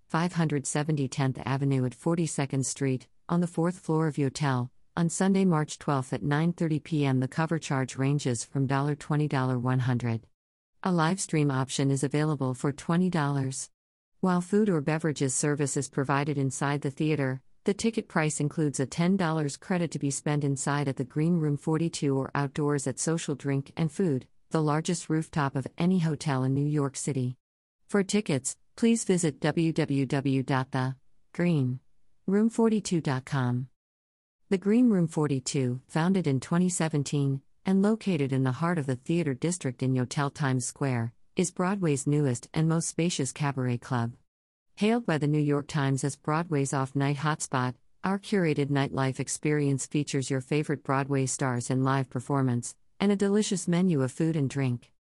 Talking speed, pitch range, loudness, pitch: 150 wpm, 135-165 Hz, -28 LUFS, 145 Hz